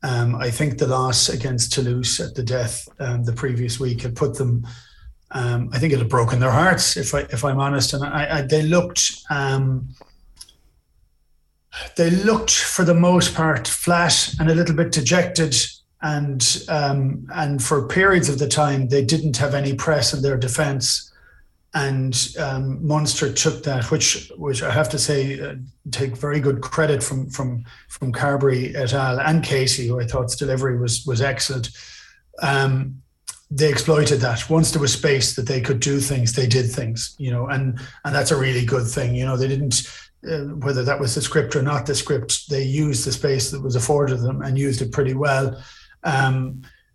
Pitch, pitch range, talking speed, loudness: 135 Hz, 125-145 Hz, 190 wpm, -20 LUFS